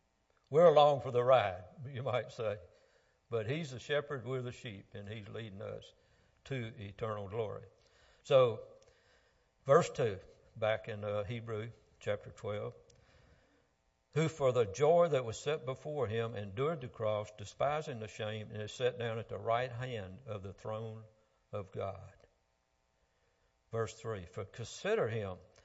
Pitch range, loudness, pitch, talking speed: 105-130 Hz, -35 LUFS, 115 Hz, 150 wpm